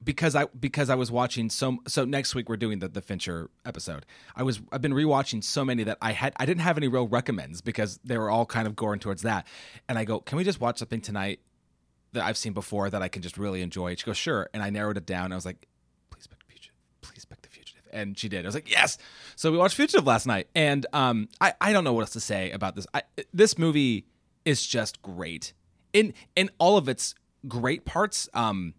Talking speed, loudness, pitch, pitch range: 250 wpm, -27 LUFS, 115 Hz, 100-140 Hz